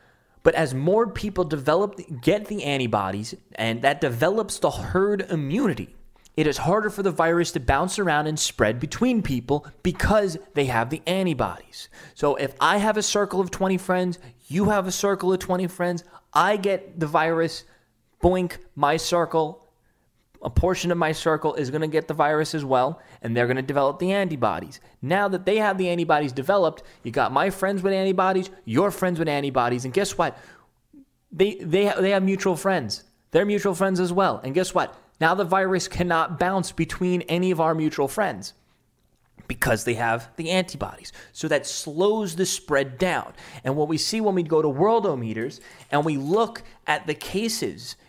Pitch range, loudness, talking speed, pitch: 145-190 Hz, -23 LUFS, 180 wpm, 170 Hz